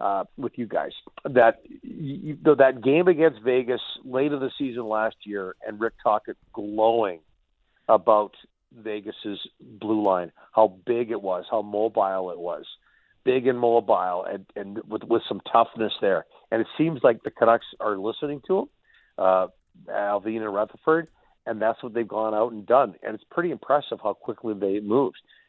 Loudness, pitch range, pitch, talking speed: -24 LUFS, 105-135 Hz, 115 Hz, 170 wpm